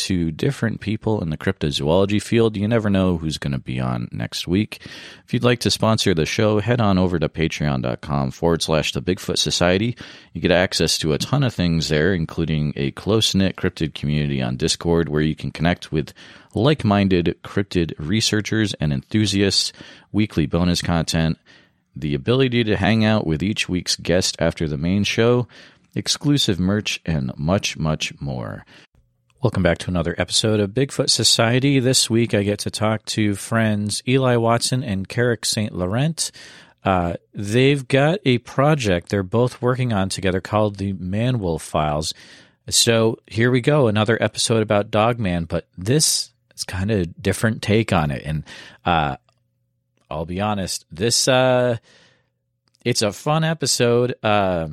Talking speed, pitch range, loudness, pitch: 165 wpm, 85-115 Hz, -20 LUFS, 105 Hz